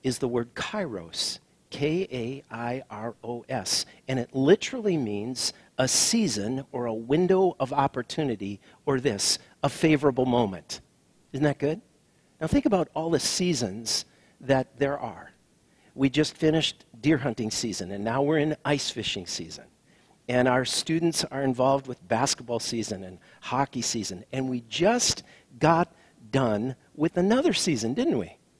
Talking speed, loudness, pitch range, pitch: 150 wpm, -26 LUFS, 120-155 Hz, 130 Hz